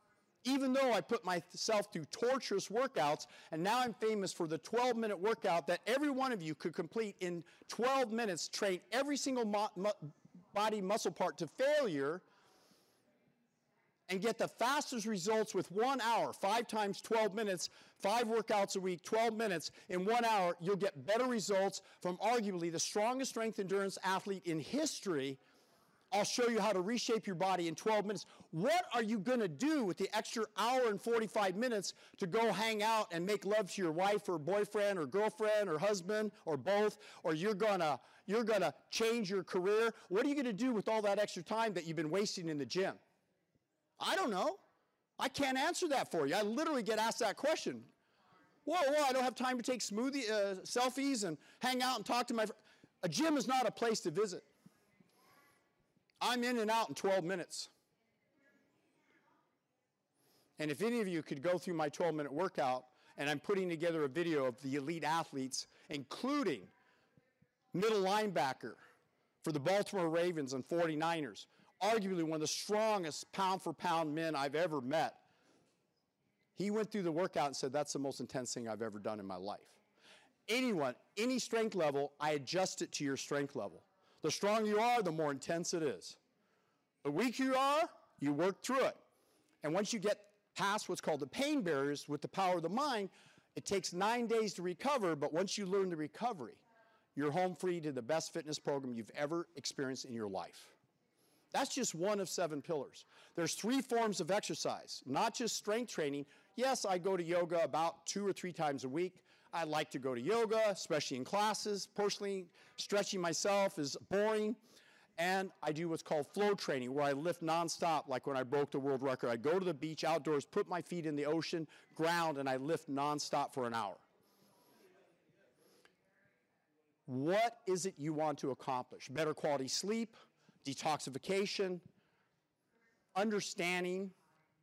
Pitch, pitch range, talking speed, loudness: 195 Hz, 160-220 Hz, 185 wpm, -37 LUFS